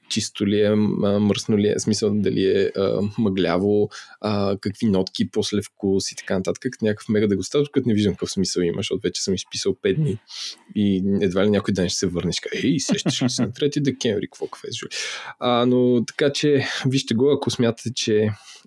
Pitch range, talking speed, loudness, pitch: 100-130 Hz, 205 wpm, -22 LUFS, 105 Hz